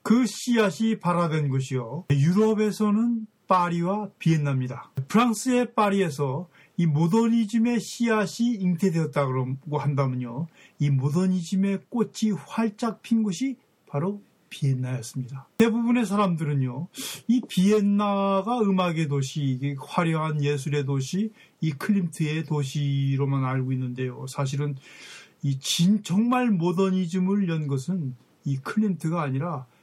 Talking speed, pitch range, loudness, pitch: 280 characters per minute, 140-210 Hz, -25 LUFS, 175 Hz